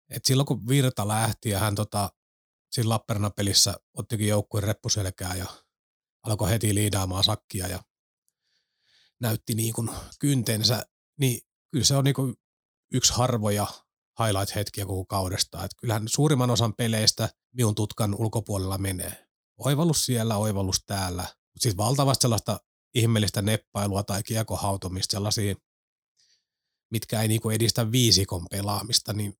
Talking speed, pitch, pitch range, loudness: 130 wpm, 110 Hz, 100-120 Hz, -26 LUFS